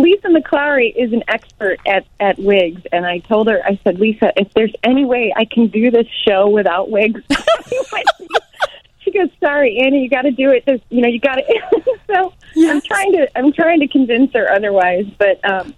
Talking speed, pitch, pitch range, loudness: 200 wpm, 245 Hz, 205-305 Hz, -14 LUFS